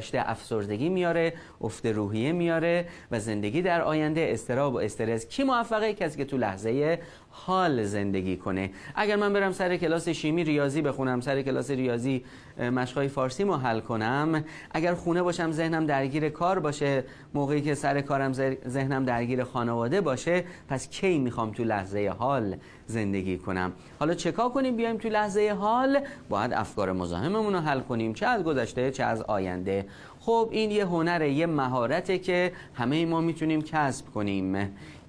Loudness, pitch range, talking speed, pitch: -28 LUFS, 115-170 Hz, 155 wpm, 140 Hz